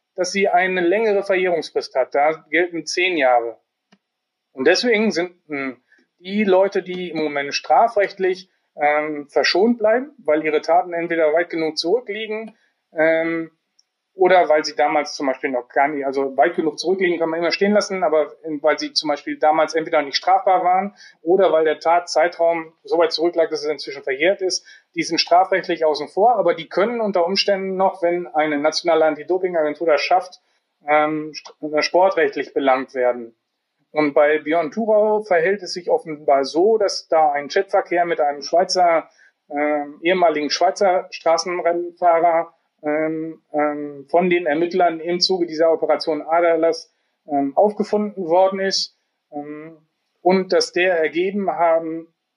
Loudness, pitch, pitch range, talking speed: -19 LUFS, 165 Hz, 155-185 Hz, 150 wpm